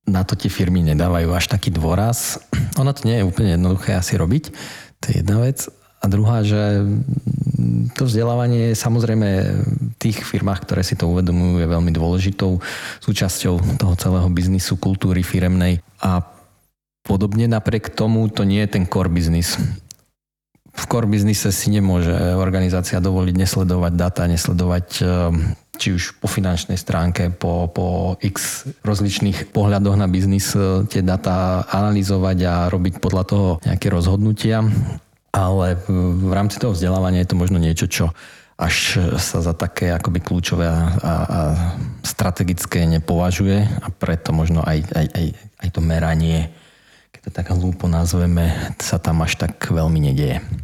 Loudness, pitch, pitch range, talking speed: -19 LUFS, 95 Hz, 90-105 Hz, 145 wpm